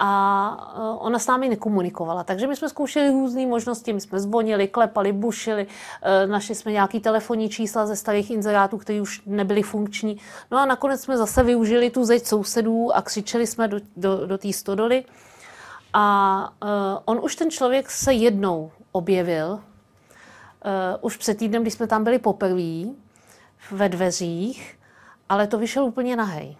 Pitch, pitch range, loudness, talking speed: 215 Hz, 200-235 Hz, -22 LUFS, 155 wpm